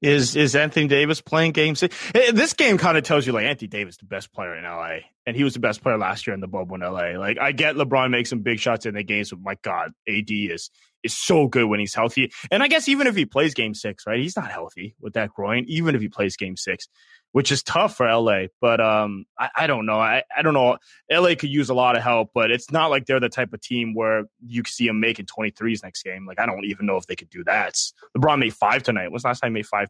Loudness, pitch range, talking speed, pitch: -21 LUFS, 105-145 Hz, 285 wpm, 120 Hz